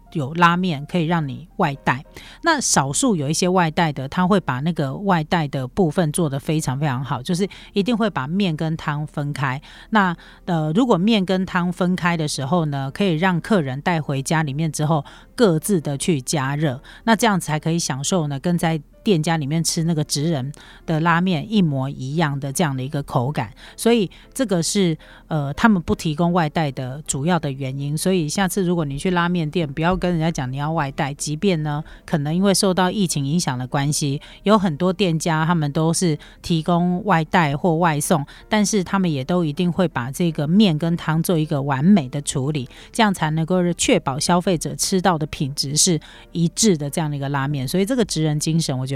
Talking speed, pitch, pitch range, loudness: 300 characters per minute, 165 Hz, 150-185 Hz, -20 LUFS